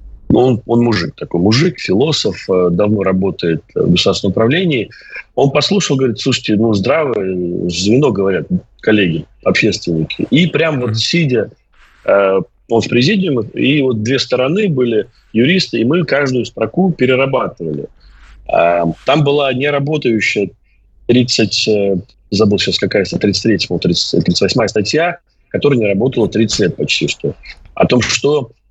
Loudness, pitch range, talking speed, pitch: -14 LUFS, 100-135 Hz, 125 wpm, 115 Hz